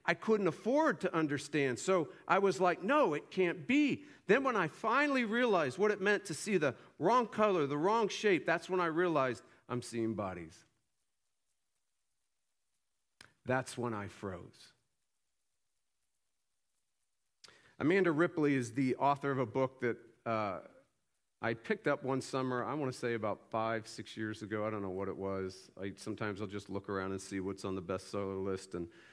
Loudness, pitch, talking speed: -34 LUFS, 130 Hz, 175 wpm